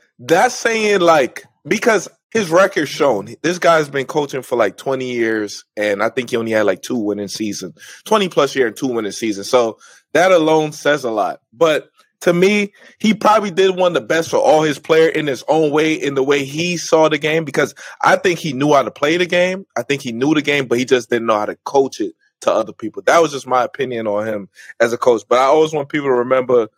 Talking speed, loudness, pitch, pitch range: 240 wpm, -16 LUFS, 145 Hz, 120-170 Hz